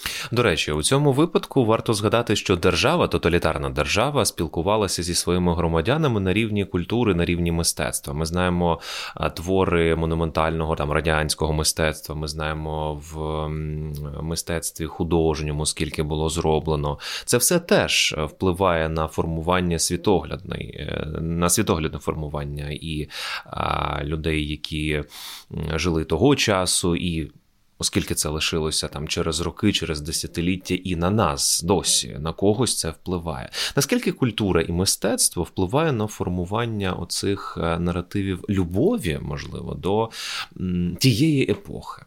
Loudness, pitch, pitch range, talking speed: -23 LUFS, 85 Hz, 80-95 Hz, 120 wpm